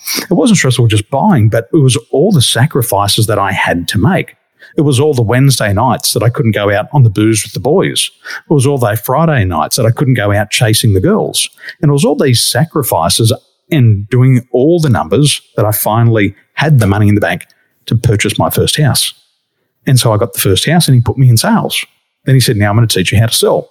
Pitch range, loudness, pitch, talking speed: 105-140 Hz, -11 LUFS, 120 Hz, 245 wpm